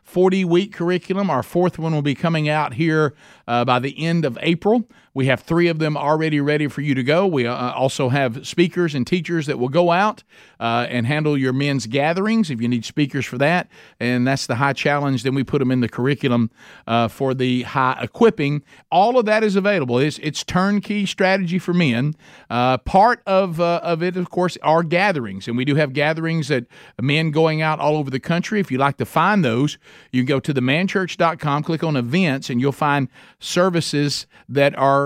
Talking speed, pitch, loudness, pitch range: 210 wpm, 150 Hz, -19 LUFS, 130-175 Hz